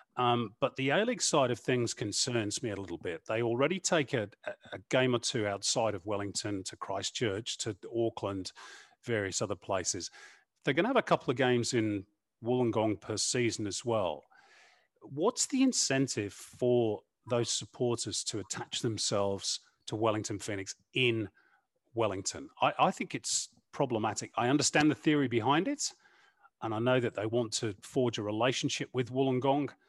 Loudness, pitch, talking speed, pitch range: -32 LUFS, 120 Hz, 165 wpm, 105-130 Hz